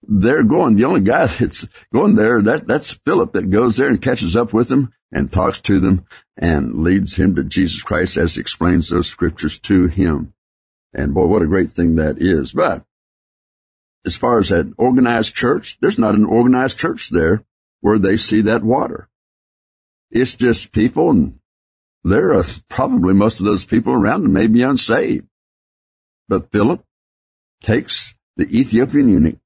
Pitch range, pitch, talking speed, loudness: 80-115 Hz, 95 Hz, 170 wpm, -16 LUFS